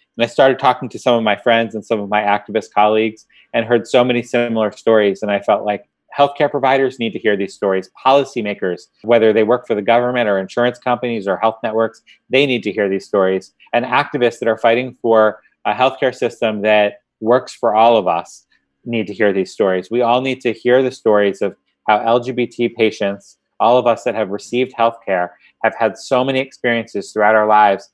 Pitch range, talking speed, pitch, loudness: 105-125 Hz, 210 wpm, 115 Hz, -16 LUFS